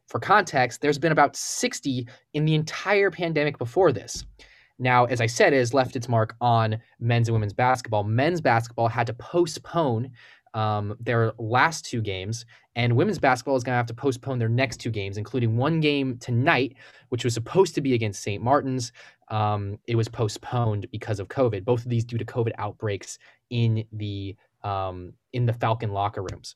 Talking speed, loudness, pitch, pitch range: 190 wpm, -25 LUFS, 120 Hz, 110-130 Hz